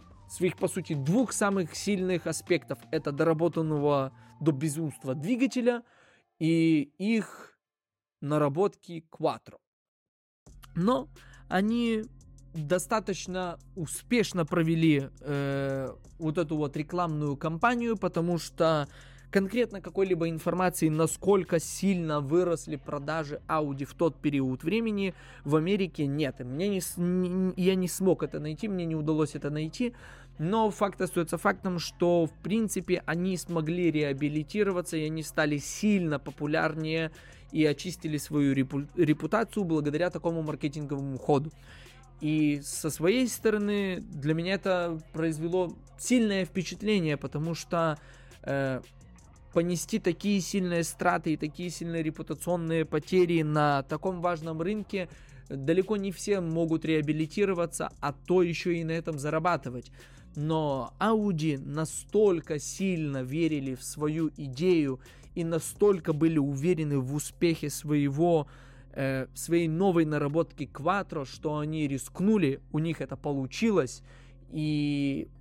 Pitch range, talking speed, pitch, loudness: 145-180 Hz, 115 wpm, 160 Hz, -29 LUFS